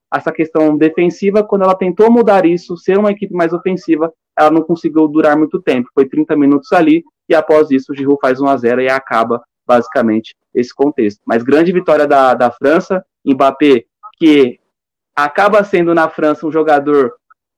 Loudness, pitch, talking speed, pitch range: -12 LUFS, 155 Hz, 165 wpm, 140-175 Hz